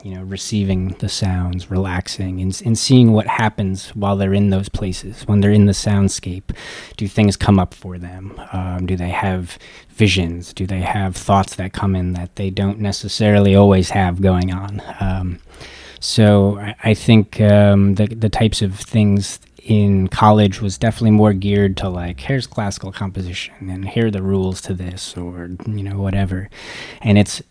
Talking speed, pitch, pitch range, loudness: 180 wpm, 100 Hz, 95-105 Hz, -17 LUFS